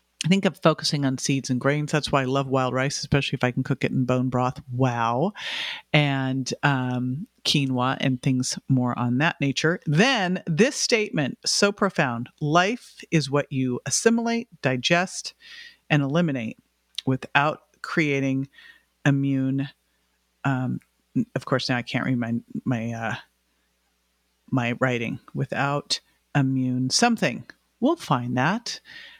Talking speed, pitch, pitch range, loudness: 140 wpm, 135 Hz, 125-170 Hz, -24 LUFS